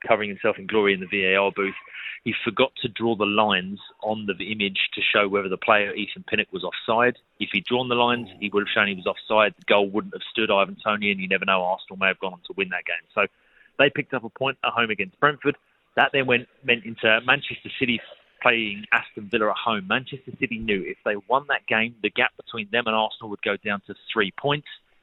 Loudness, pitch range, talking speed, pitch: -23 LUFS, 100-125 Hz, 235 wpm, 110 Hz